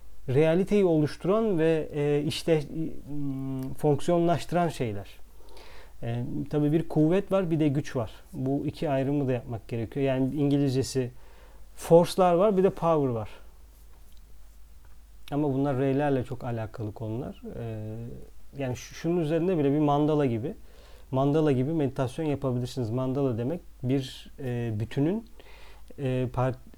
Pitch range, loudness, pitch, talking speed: 120-155 Hz, -27 LUFS, 135 Hz, 110 wpm